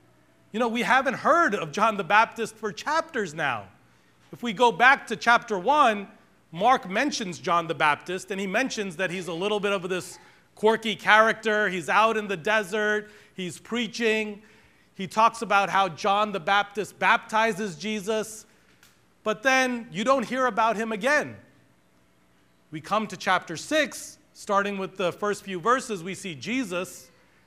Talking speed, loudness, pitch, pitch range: 160 wpm, -24 LUFS, 210 Hz, 185-225 Hz